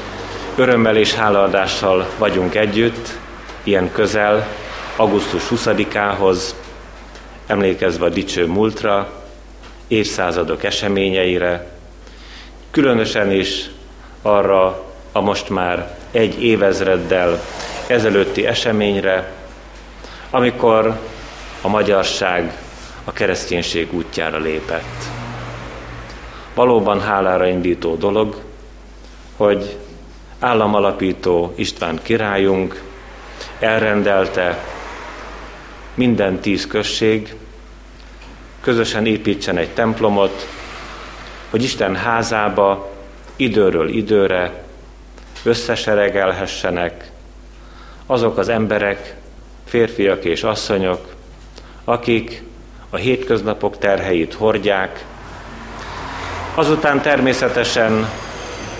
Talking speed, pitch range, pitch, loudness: 70 wpm, 90-110 Hz, 100 Hz, -17 LUFS